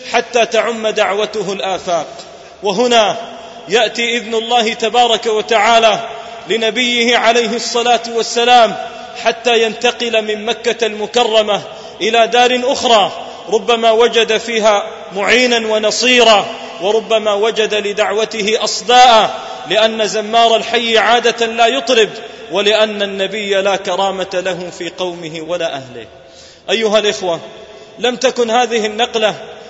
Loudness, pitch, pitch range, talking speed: -13 LUFS, 225 Hz, 215-235 Hz, 105 wpm